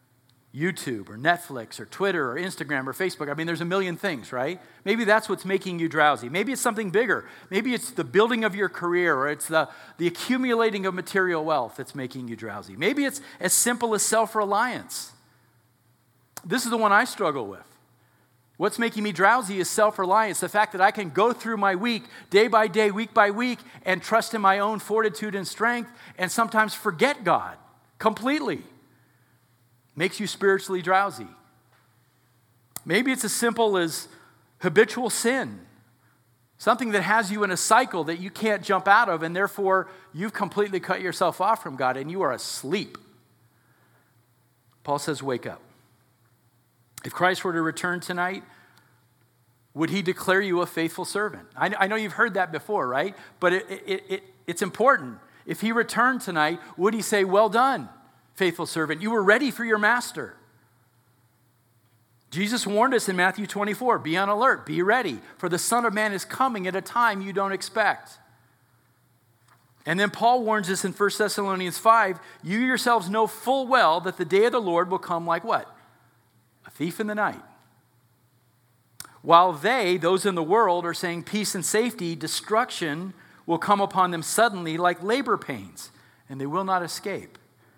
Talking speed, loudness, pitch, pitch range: 175 wpm, -24 LUFS, 185 Hz, 145-215 Hz